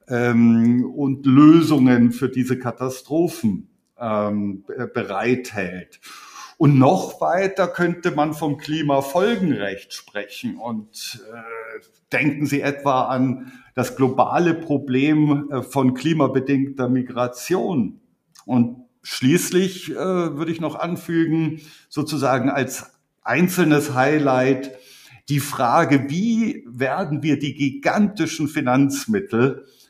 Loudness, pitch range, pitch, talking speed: -20 LUFS, 125-165 Hz, 140 Hz, 90 wpm